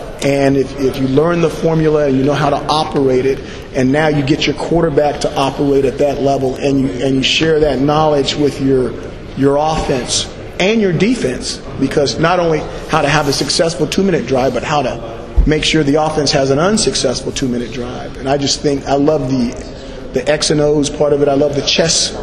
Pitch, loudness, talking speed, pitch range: 145 Hz, -14 LUFS, 220 wpm, 135-155 Hz